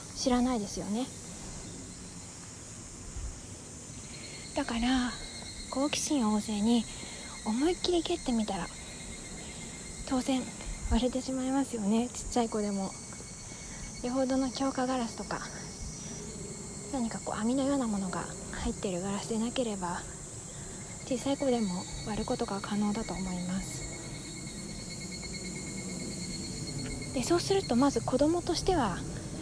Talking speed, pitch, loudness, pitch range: 235 characters per minute, 230 Hz, -33 LUFS, 190-260 Hz